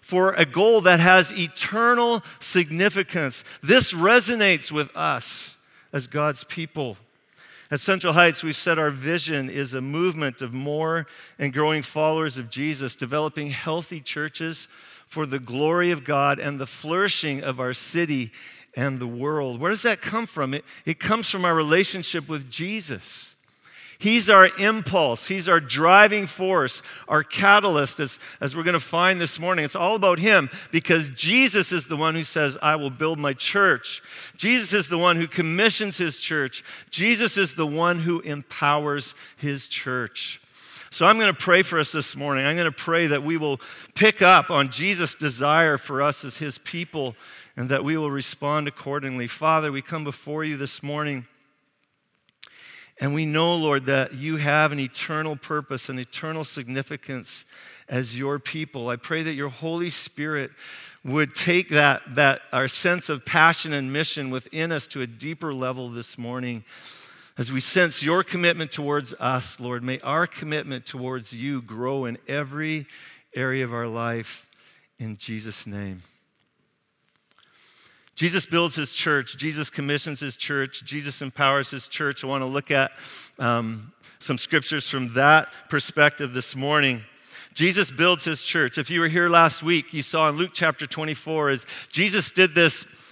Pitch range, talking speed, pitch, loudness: 135-170 Hz, 165 wpm, 150 Hz, -22 LUFS